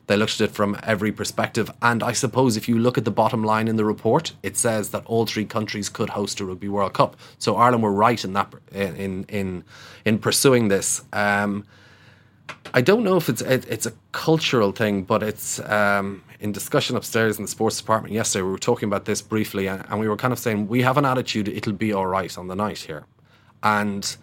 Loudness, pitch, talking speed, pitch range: -22 LUFS, 105 Hz, 225 wpm, 100-115 Hz